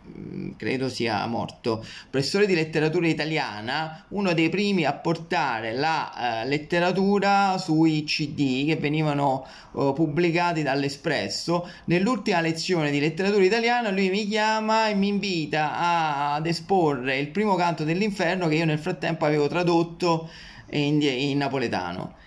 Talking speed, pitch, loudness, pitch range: 130 wpm, 165 Hz, -24 LUFS, 150-185 Hz